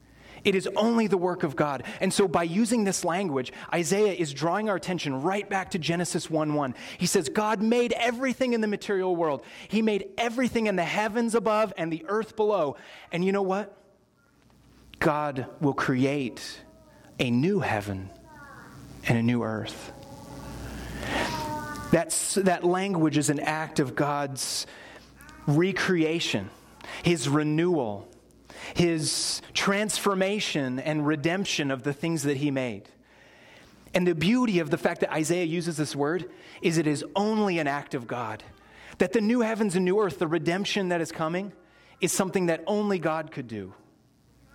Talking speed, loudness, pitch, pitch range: 155 wpm, -27 LUFS, 170 Hz, 145-200 Hz